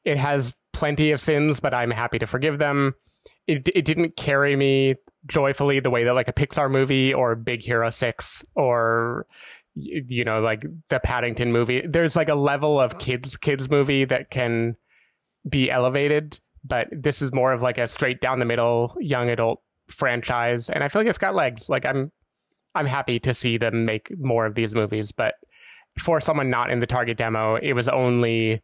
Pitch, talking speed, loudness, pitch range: 125 Hz, 190 wpm, -23 LUFS, 120-145 Hz